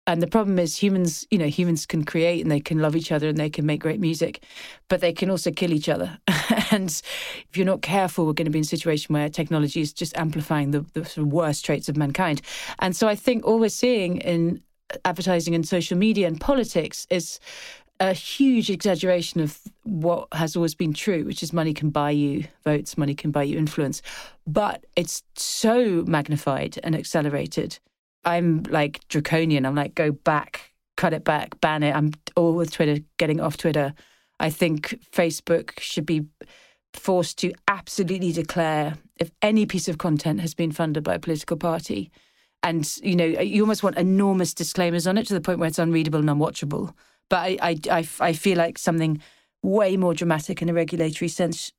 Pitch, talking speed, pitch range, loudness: 170 Hz, 195 wpm, 155-185 Hz, -24 LUFS